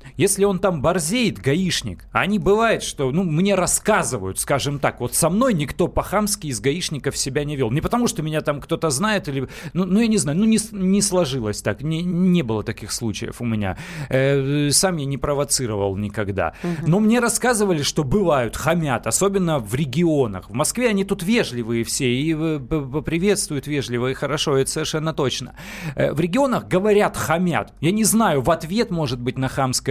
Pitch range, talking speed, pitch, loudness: 130-190 Hz, 185 wpm, 155 Hz, -20 LUFS